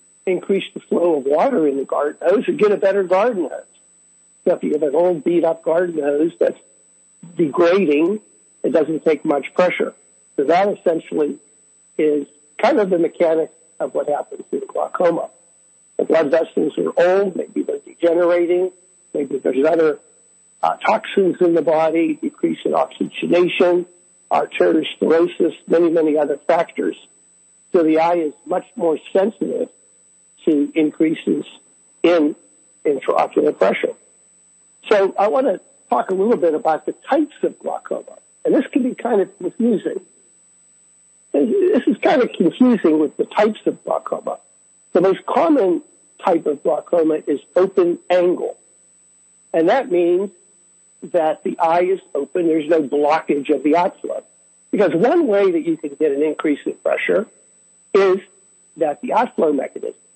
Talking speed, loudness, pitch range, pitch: 150 wpm, -18 LUFS, 160-230 Hz, 180 Hz